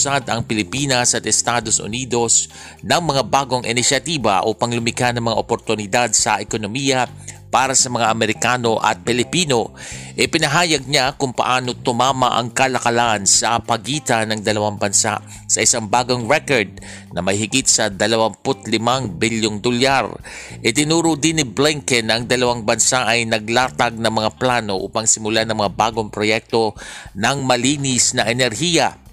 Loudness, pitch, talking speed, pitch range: -17 LUFS, 120 Hz, 140 wpm, 110-130 Hz